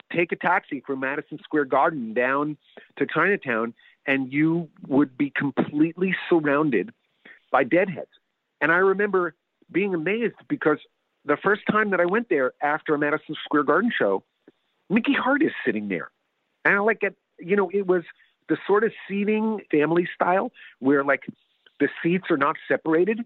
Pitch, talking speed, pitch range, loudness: 170 Hz, 160 wpm, 145-200 Hz, -23 LUFS